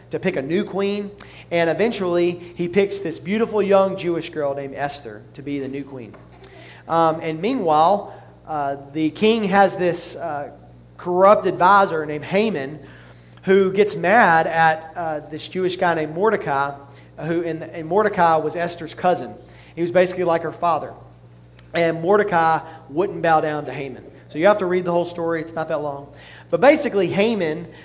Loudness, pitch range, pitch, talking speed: -20 LUFS, 150-185 Hz, 165 Hz, 170 wpm